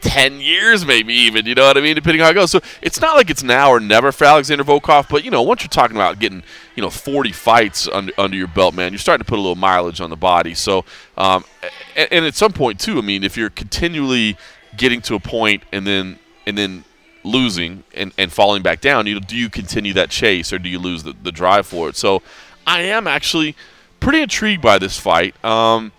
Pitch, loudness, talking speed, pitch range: 115 Hz, -15 LUFS, 240 wpm, 95-145 Hz